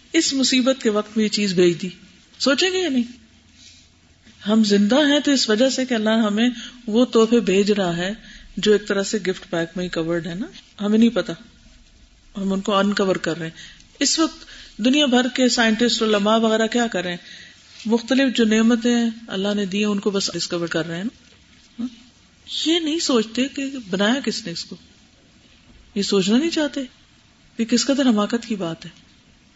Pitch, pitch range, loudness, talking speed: 220 Hz, 195-245 Hz, -20 LUFS, 195 wpm